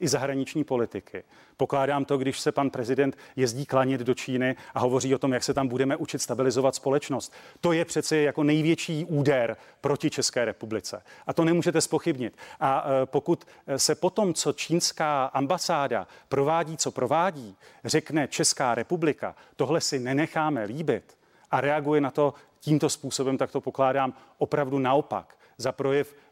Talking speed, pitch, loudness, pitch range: 155 wpm, 140 Hz, -26 LUFS, 135-155 Hz